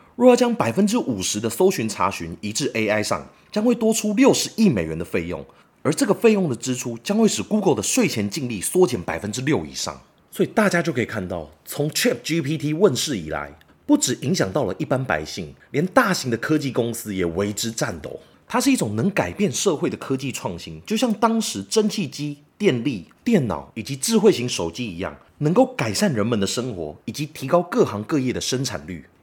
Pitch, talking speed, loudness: 145 Hz, 325 characters per minute, -22 LUFS